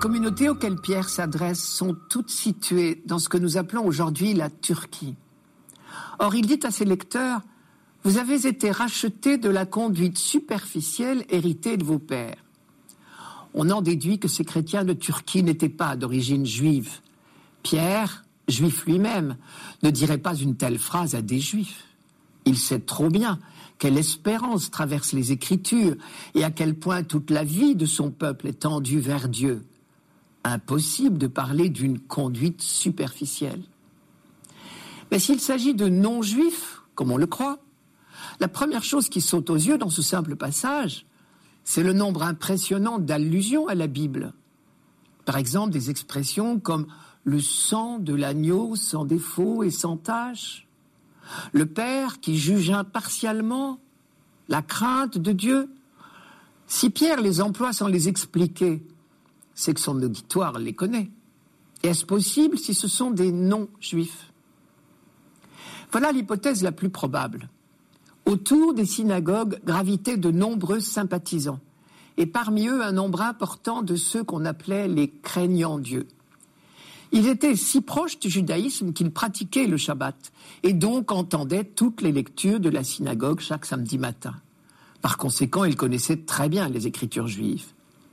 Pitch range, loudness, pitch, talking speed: 155-220 Hz, -24 LUFS, 180 Hz, 145 wpm